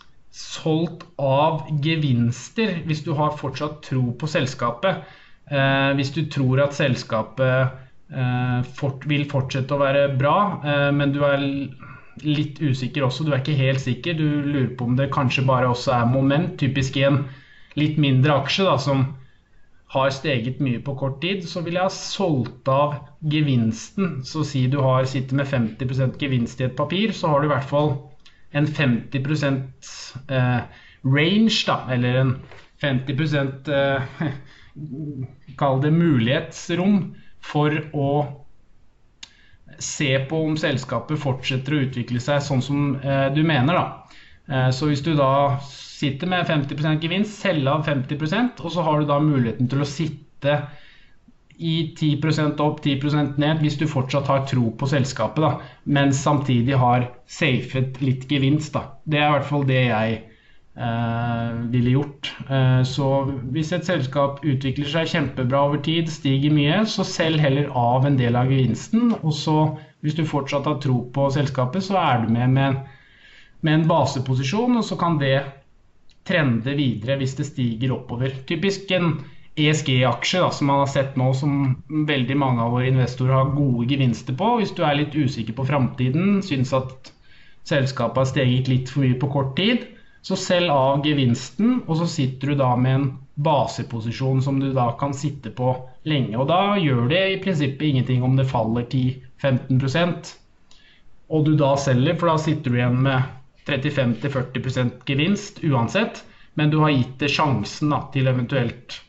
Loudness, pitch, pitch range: -22 LUFS, 140 Hz, 130-150 Hz